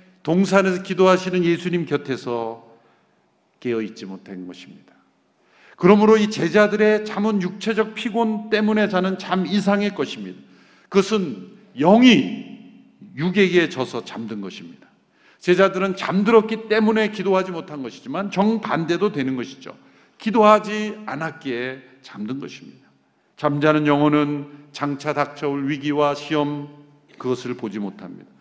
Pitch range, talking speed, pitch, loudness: 145-210 Hz, 295 characters per minute, 180 Hz, -20 LUFS